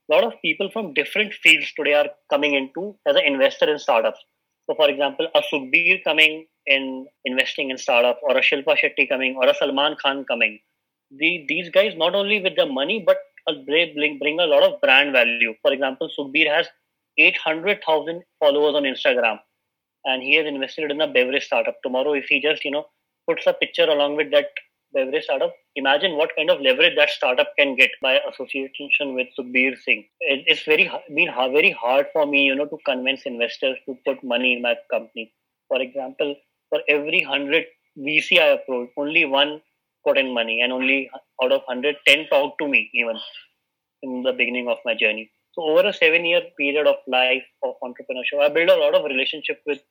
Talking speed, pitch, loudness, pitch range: 190 wpm, 150 Hz, -19 LUFS, 130-195 Hz